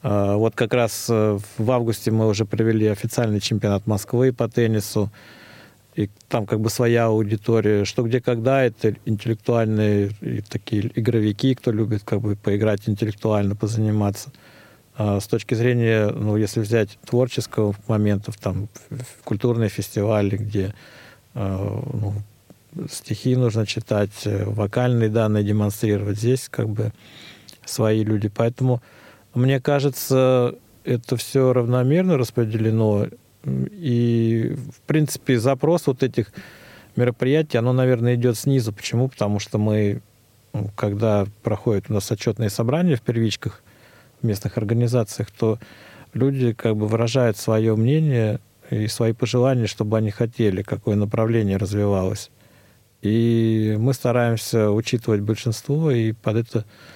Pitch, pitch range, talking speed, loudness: 115 Hz, 105-125 Hz, 120 wpm, -21 LUFS